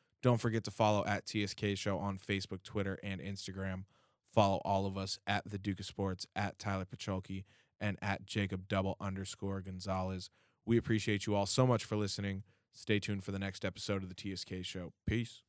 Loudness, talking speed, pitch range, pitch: -37 LUFS, 190 wpm, 95-105 Hz, 100 Hz